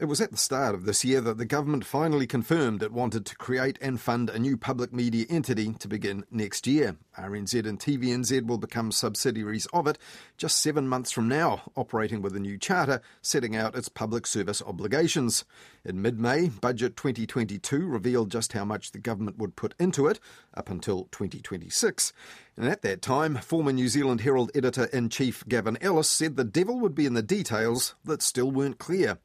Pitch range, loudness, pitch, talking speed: 110-140 Hz, -28 LUFS, 125 Hz, 195 wpm